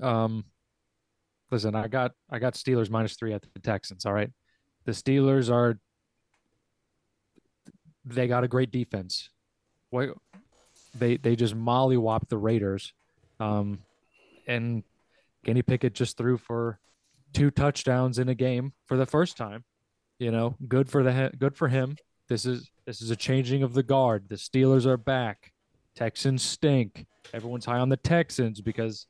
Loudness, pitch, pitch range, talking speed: -27 LUFS, 120 Hz, 110-130 Hz, 150 wpm